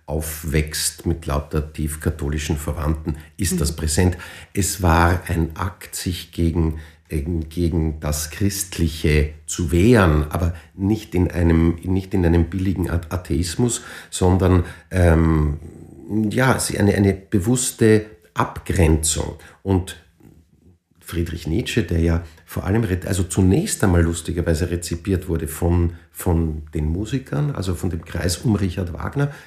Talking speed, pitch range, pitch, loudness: 120 wpm, 80-95 Hz, 85 Hz, -21 LUFS